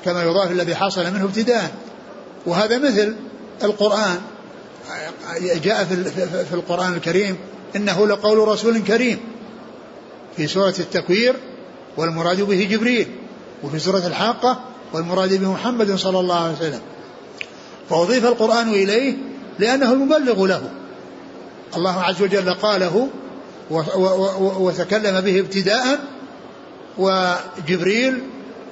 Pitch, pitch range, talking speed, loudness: 195 Hz, 180-225 Hz, 100 wpm, -19 LUFS